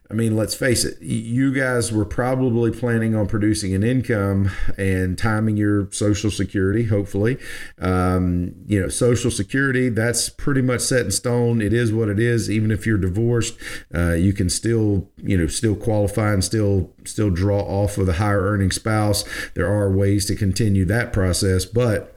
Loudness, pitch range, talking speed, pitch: -20 LUFS, 100-115 Hz, 180 wpm, 105 Hz